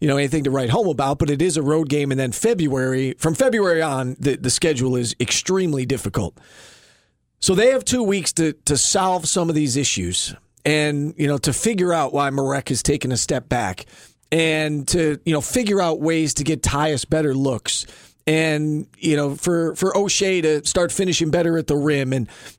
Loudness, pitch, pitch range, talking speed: -20 LUFS, 150 Hz, 135-165 Hz, 200 wpm